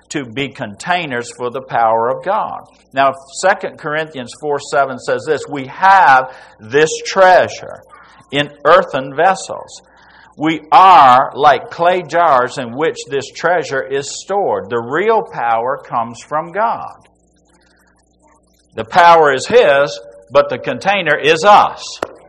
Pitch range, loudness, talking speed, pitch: 125-190 Hz, -13 LUFS, 130 wpm, 150 Hz